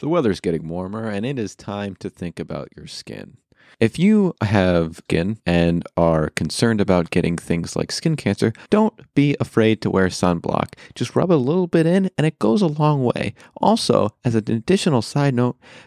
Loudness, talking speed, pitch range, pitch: -20 LUFS, 190 wpm, 90-145 Hz, 110 Hz